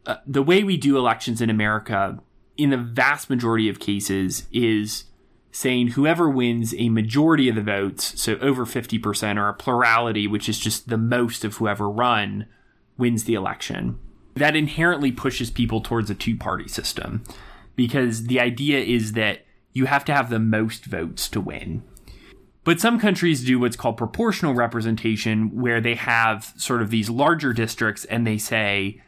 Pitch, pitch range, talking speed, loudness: 115 Hz, 110-130 Hz, 165 wpm, -22 LUFS